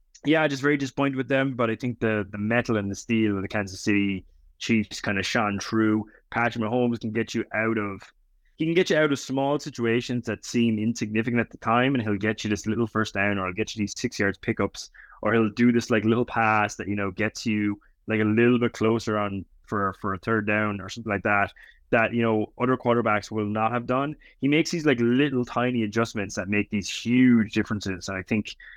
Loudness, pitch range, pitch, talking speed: -25 LUFS, 105-120 Hz, 110 Hz, 235 wpm